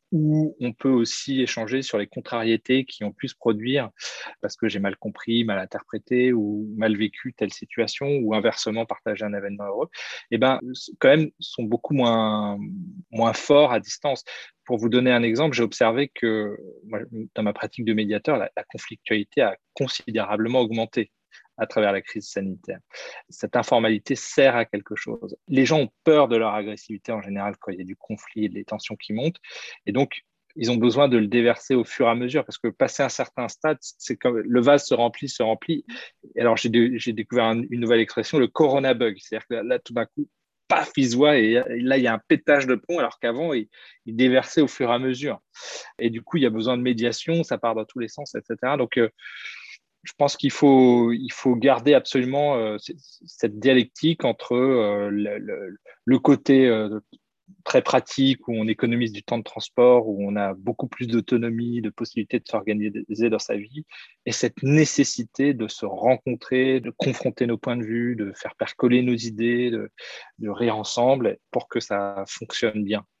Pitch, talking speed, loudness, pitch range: 120 Hz, 200 wpm, -23 LUFS, 110-130 Hz